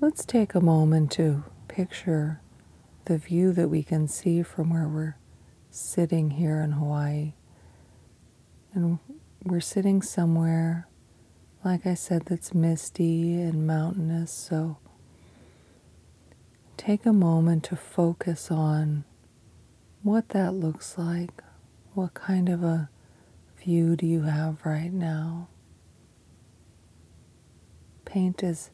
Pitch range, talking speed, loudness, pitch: 150-175 Hz, 110 wpm, -27 LUFS, 165 Hz